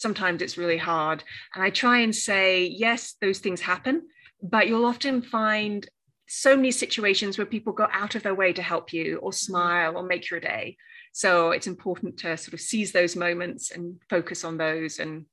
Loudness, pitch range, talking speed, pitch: -25 LUFS, 175-220 Hz, 195 wpm, 190 Hz